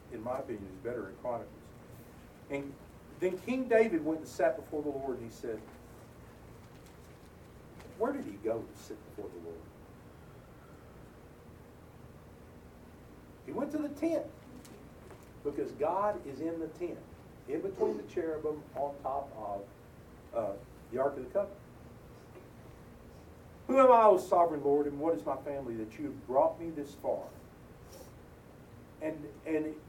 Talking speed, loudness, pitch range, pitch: 145 wpm, -33 LUFS, 120-200 Hz, 150 Hz